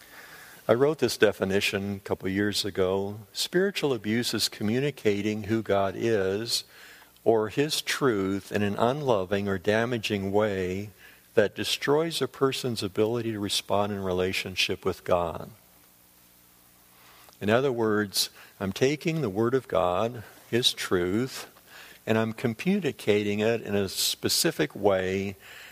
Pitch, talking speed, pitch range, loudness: 105 Hz, 125 wpm, 95-115 Hz, -27 LUFS